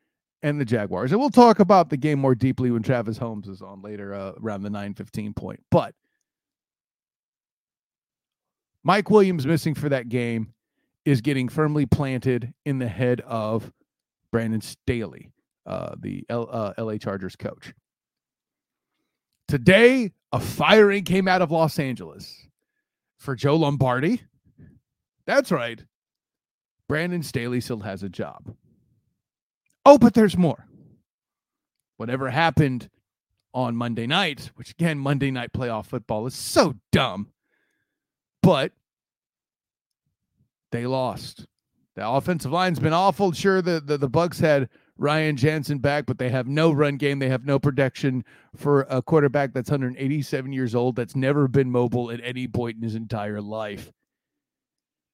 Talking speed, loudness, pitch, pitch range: 140 wpm, -22 LUFS, 135 Hz, 120-155 Hz